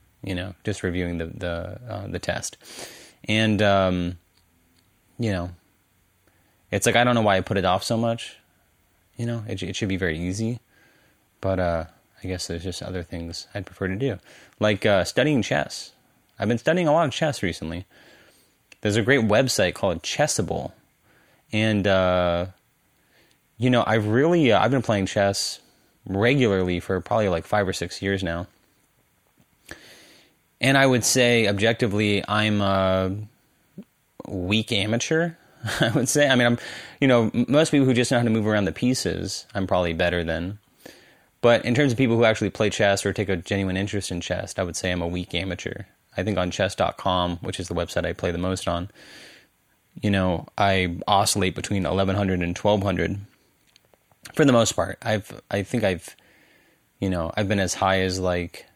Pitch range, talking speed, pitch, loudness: 90-110 Hz, 180 wpm, 100 Hz, -23 LUFS